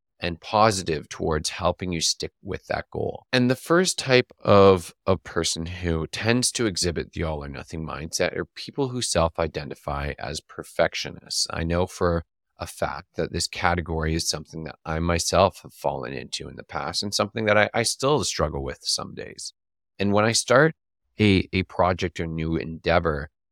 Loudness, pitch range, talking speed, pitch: -24 LUFS, 80-105 Hz, 175 wpm, 85 Hz